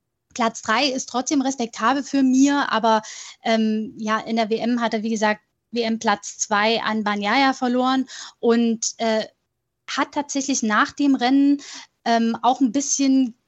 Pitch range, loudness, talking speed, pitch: 225-270 Hz, -21 LUFS, 145 wpm, 235 Hz